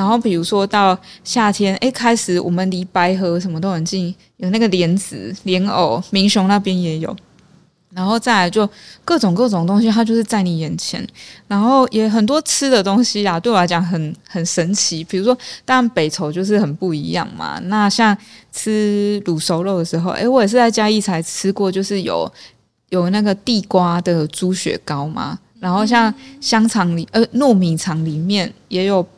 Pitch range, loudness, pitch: 175-220 Hz, -17 LUFS, 195 Hz